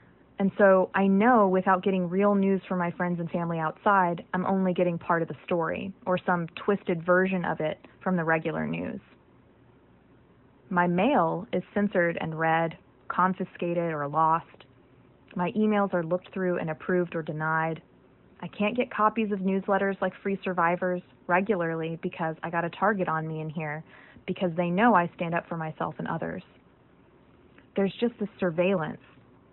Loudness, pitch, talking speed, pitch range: -27 LUFS, 180 Hz, 165 wpm, 165-195 Hz